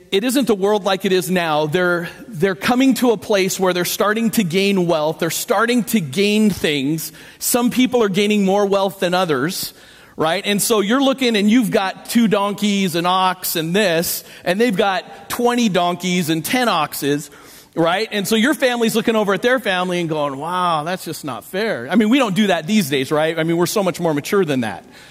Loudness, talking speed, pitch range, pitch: -17 LUFS, 215 wpm, 175-225 Hz, 195 Hz